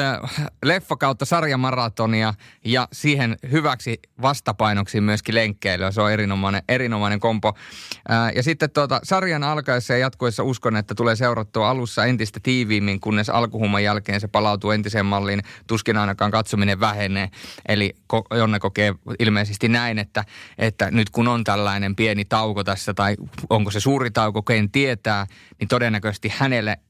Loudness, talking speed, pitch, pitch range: -21 LUFS, 145 wpm, 110 Hz, 105-125 Hz